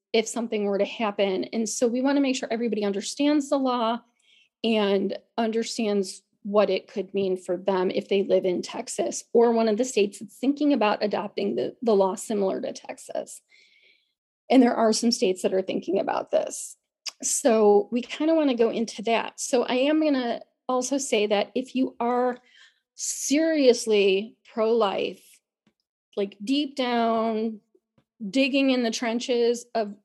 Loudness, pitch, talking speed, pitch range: -25 LUFS, 230 Hz, 170 wpm, 210-255 Hz